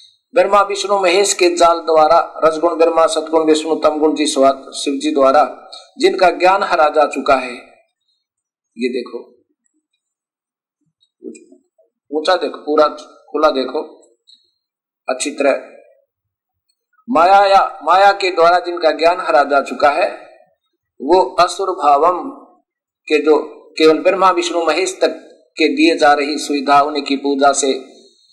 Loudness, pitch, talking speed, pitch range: -14 LUFS, 165 Hz, 120 wpm, 150-200 Hz